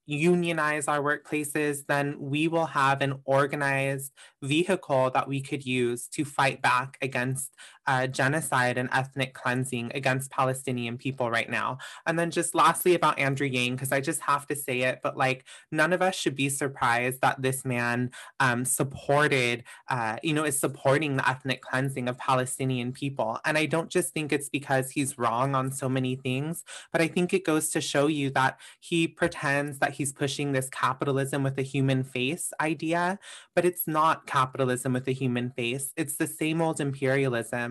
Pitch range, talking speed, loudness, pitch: 130-155 Hz, 180 wpm, -27 LUFS, 140 Hz